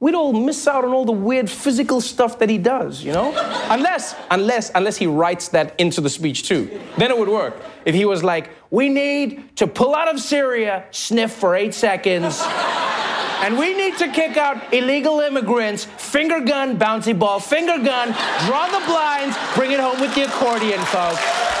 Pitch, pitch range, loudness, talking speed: 250 Hz, 205-285 Hz, -19 LUFS, 190 wpm